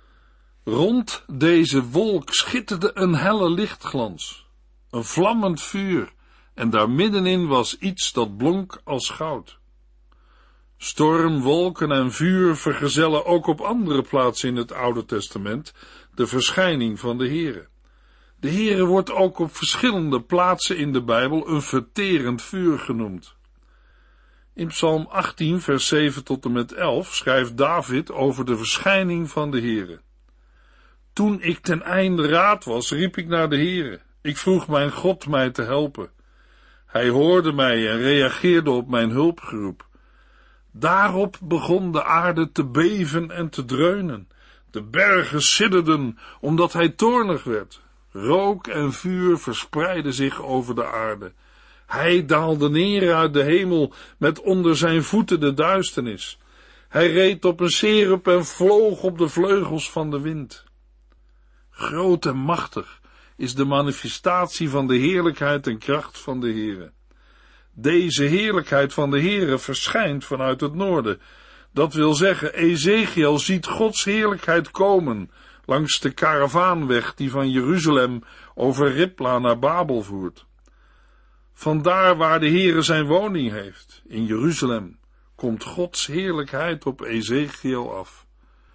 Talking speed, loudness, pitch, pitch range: 135 wpm, -21 LUFS, 155 Hz, 130-180 Hz